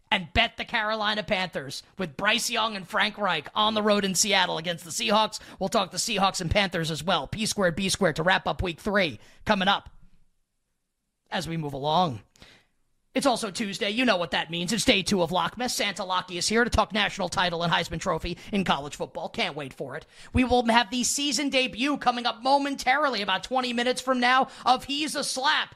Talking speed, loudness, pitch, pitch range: 210 wpm, -25 LUFS, 210 Hz, 185-245 Hz